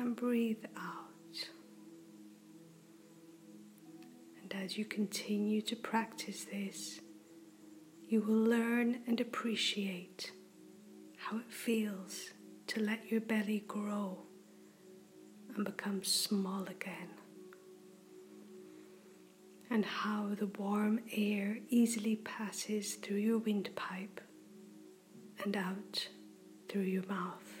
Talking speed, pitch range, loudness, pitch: 90 wpm, 170-215 Hz, -37 LUFS, 200 Hz